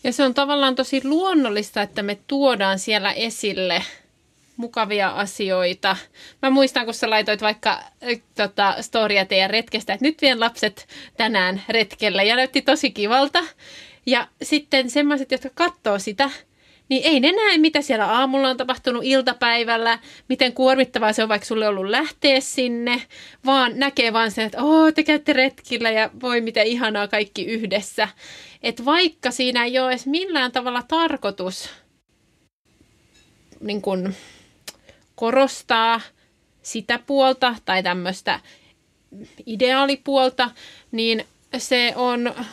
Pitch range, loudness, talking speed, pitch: 215-270 Hz, -20 LUFS, 130 wpm, 245 Hz